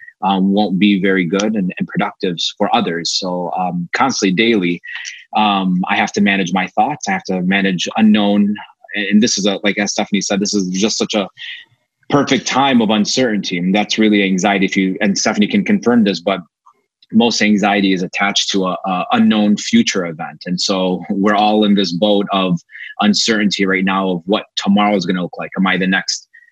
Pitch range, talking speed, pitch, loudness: 95-105 Hz, 200 wpm, 100 Hz, -15 LUFS